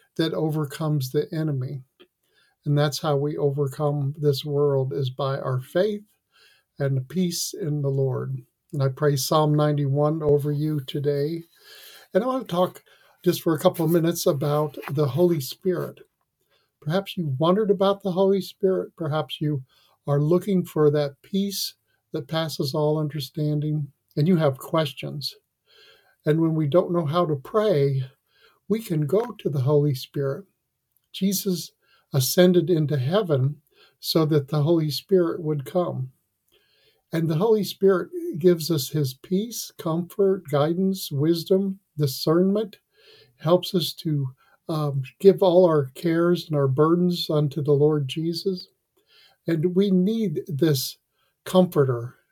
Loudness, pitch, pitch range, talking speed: -24 LUFS, 155 Hz, 145-185 Hz, 140 wpm